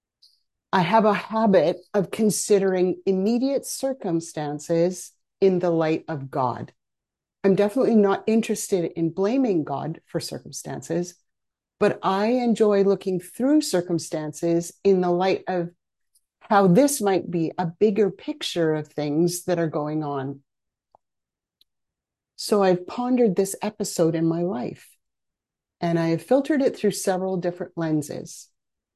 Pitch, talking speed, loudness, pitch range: 185 Hz, 130 wpm, -23 LUFS, 165-205 Hz